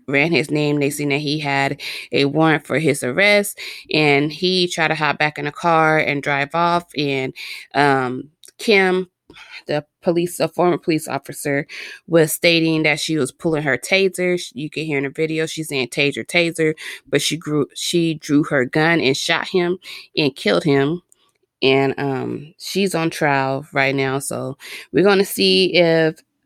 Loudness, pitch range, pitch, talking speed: -18 LUFS, 140-175 Hz, 155 Hz, 175 wpm